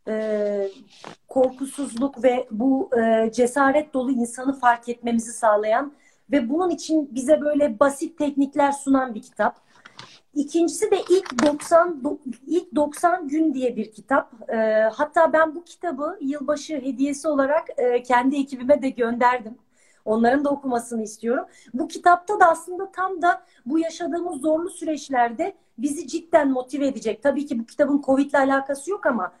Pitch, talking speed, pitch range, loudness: 280 Hz, 135 wpm, 245-320 Hz, -22 LUFS